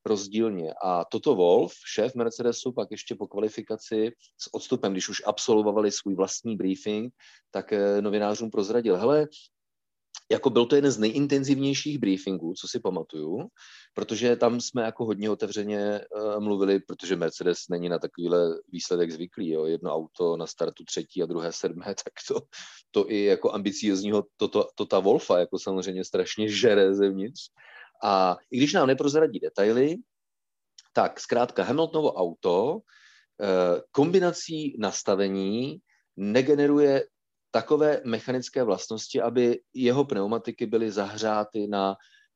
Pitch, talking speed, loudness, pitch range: 110 Hz, 135 wpm, -26 LUFS, 100-130 Hz